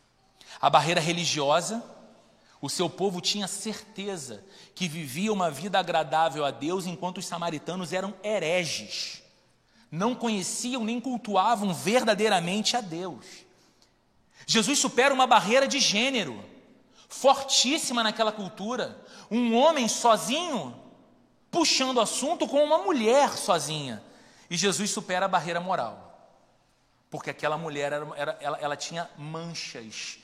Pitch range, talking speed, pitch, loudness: 165-235 Hz, 120 wpm, 195 Hz, -26 LUFS